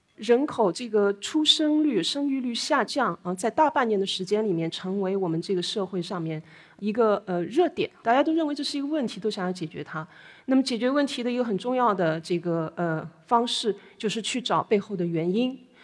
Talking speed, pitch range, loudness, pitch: 305 characters per minute, 180-265 Hz, -26 LUFS, 215 Hz